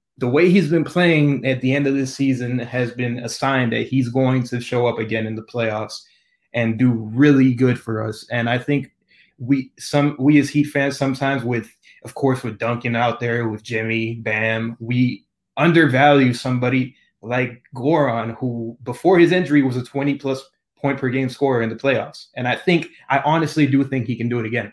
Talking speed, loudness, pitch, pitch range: 200 wpm, -19 LUFS, 130 Hz, 120-140 Hz